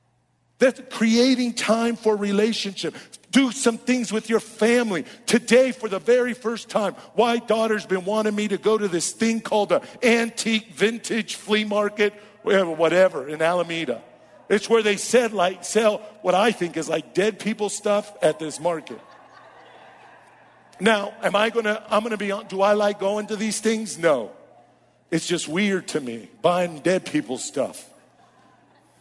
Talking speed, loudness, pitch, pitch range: 160 wpm, -22 LUFS, 210 Hz, 190-225 Hz